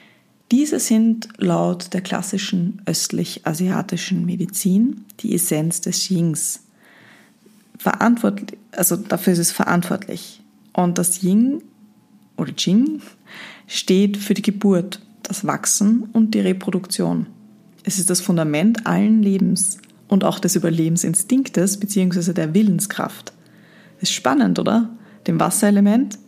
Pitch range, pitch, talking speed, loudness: 185-220 Hz, 200 Hz, 110 wpm, -19 LUFS